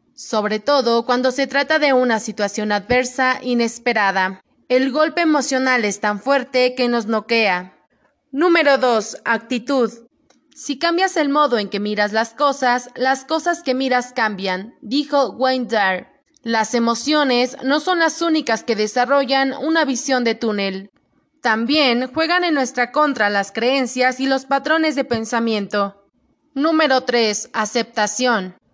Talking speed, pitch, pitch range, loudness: 135 wpm, 250 Hz, 225-280 Hz, -18 LUFS